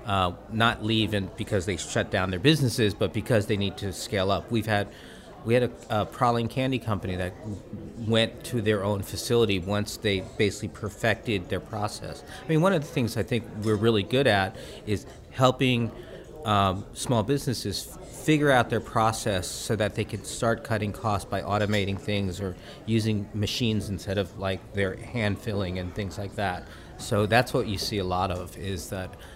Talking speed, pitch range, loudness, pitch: 190 wpm, 100-115 Hz, -27 LUFS, 105 Hz